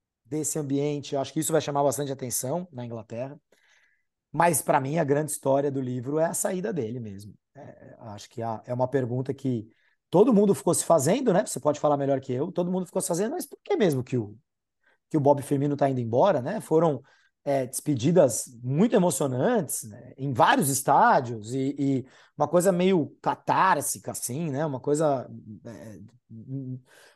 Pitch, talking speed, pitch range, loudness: 140 Hz, 185 wpm, 125-160 Hz, -25 LUFS